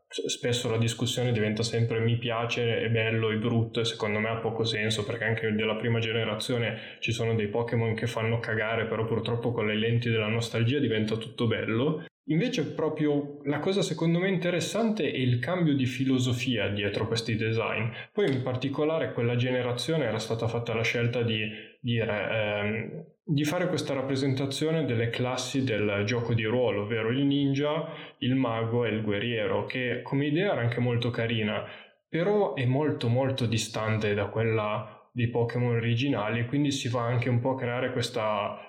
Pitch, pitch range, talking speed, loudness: 120 Hz, 115-135 Hz, 170 wpm, -28 LUFS